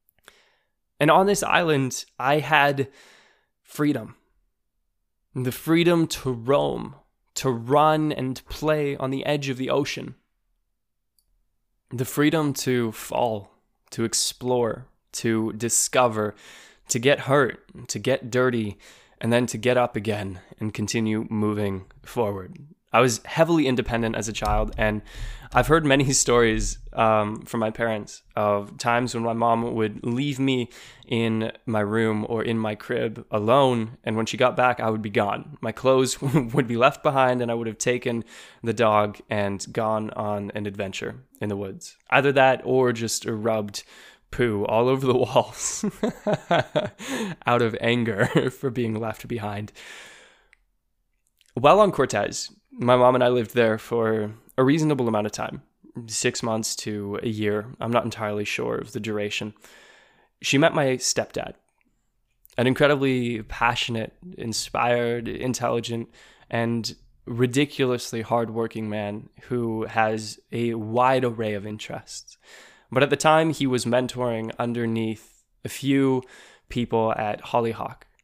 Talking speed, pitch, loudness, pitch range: 140 wpm, 120 Hz, -24 LUFS, 110-130 Hz